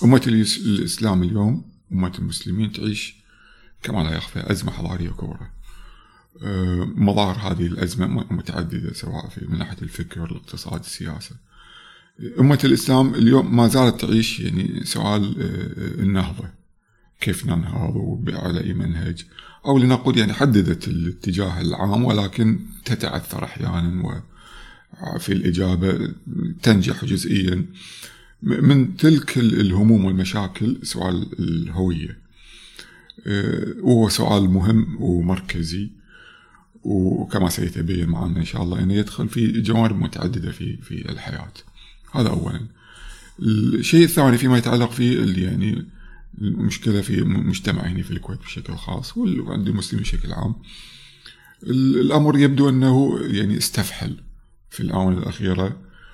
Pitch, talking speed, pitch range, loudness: 100 Hz, 110 wpm, 90-120 Hz, -21 LUFS